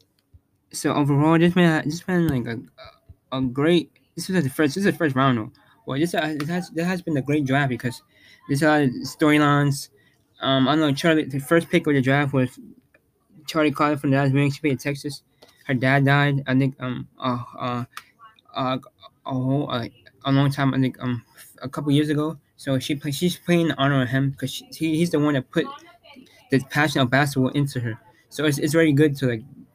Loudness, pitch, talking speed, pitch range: -22 LUFS, 145 Hz, 215 wpm, 130-155 Hz